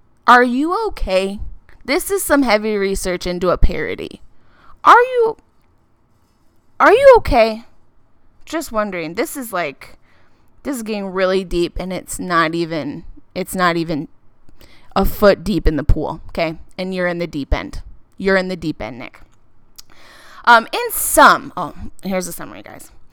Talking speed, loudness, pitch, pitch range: 155 wpm, -16 LUFS, 185 Hz, 165-240 Hz